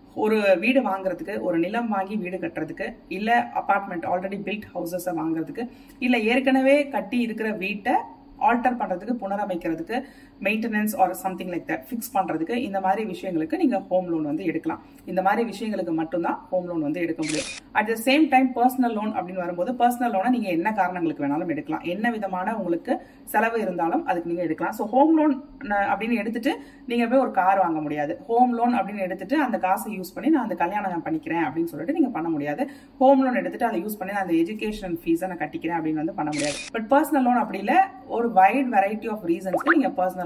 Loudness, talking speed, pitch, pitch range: -24 LUFS, 160 wpm, 205 Hz, 180-255 Hz